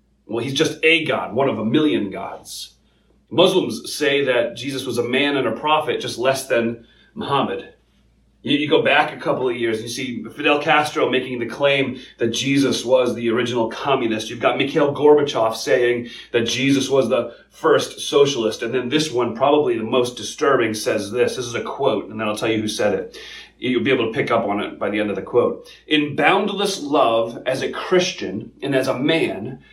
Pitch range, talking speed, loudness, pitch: 115-150 Hz, 205 wpm, -19 LUFS, 135 Hz